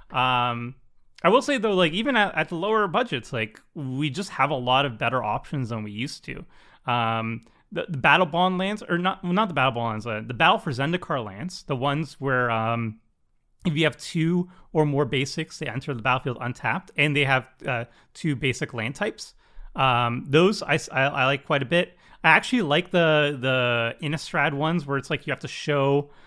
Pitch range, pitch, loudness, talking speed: 125-170 Hz, 145 Hz, -24 LUFS, 210 wpm